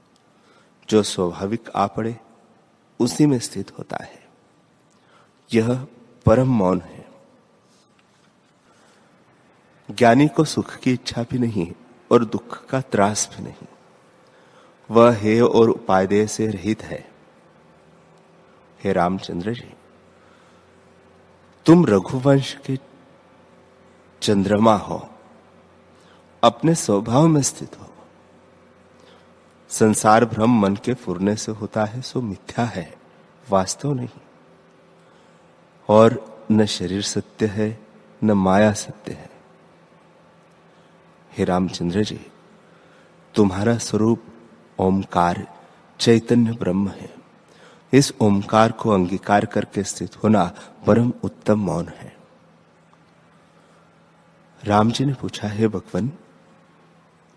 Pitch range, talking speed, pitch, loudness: 100-135 Hz, 95 wpm, 115 Hz, -20 LUFS